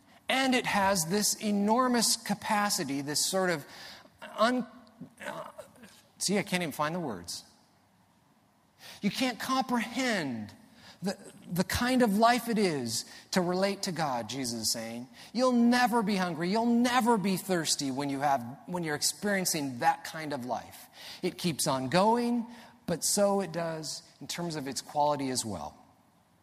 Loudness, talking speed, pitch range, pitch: -29 LUFS, 155 wpm, 150-225 Hz, 185 Hz